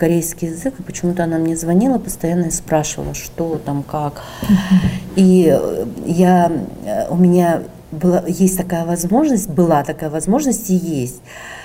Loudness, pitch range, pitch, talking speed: -17 LUFS, 160-185 Hz, 170 Hz, 135 wpm